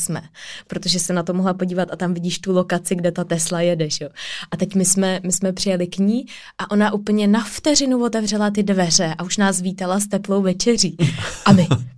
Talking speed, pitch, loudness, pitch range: 210 wpm, 185 Hz, -19 LUFS, 175-200 Hz